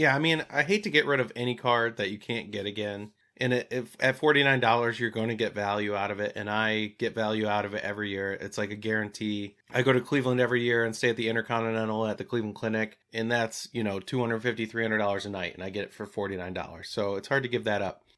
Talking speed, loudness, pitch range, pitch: 280 wpm, -28 LUFS, 105-120 Hz, 110 Hz